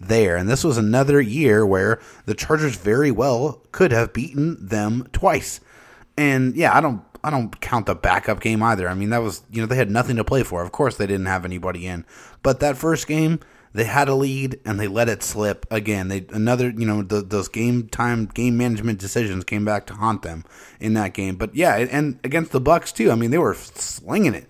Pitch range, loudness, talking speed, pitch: 105-130 Hz, -21 LUFS, 225 wpm, 115 Hz